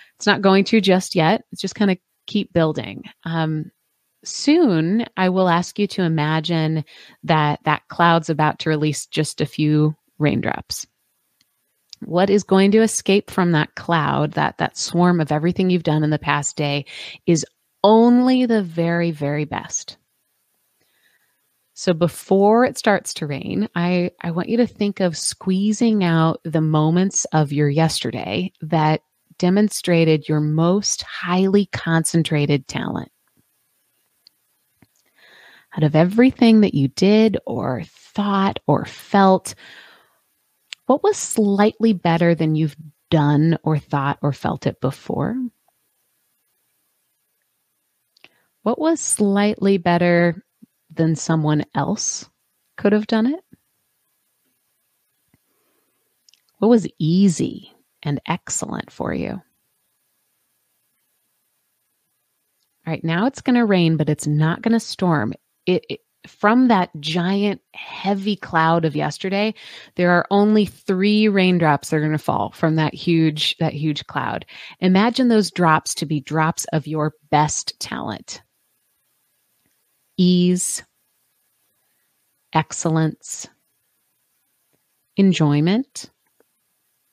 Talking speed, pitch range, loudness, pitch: 120 wpm, 155-205 Hz, -19 LUFS, 175 Hz